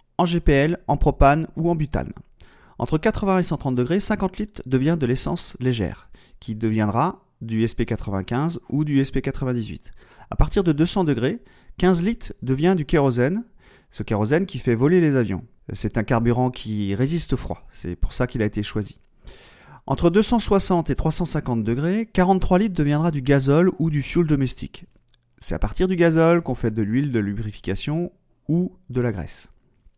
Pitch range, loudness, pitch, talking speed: 115-170 Hz, -22 LUFS, 135 Hz, 170 wpm